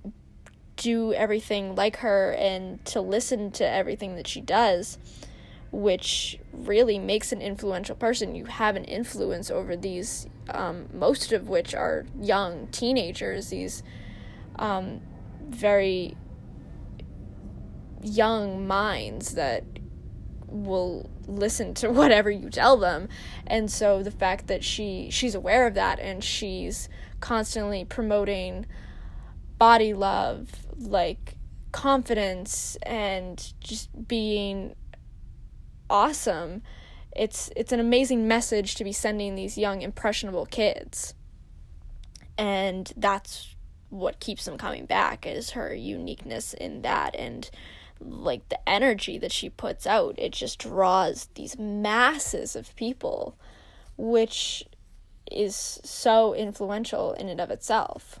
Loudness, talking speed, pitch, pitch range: -26 LUFS, 115 wpm, 210 Hz, 190-230 Hz